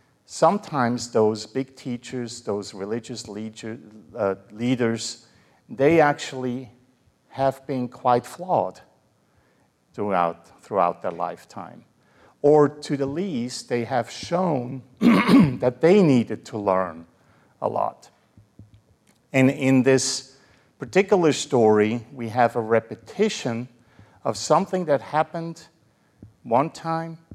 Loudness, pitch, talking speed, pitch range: -23 LUFS, 125 Hz, 100 wpm, 110-145 Hz